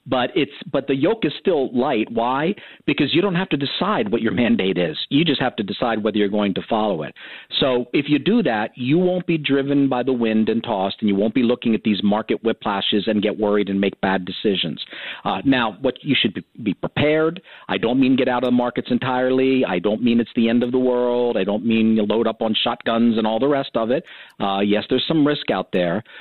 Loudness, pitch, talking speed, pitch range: -20 LUFS, 120 Hz, 265 wpm, 105-130 Hz